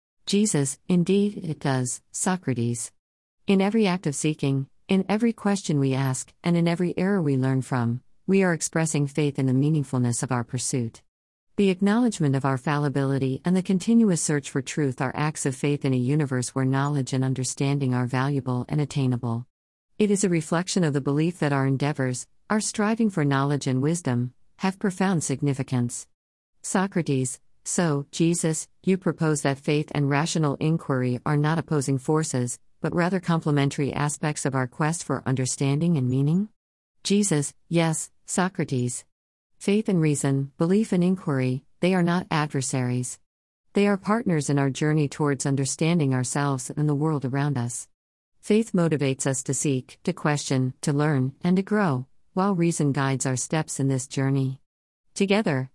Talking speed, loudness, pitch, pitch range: 160 wpm, -25 LUFS, 145 Hz, 130-170 Hz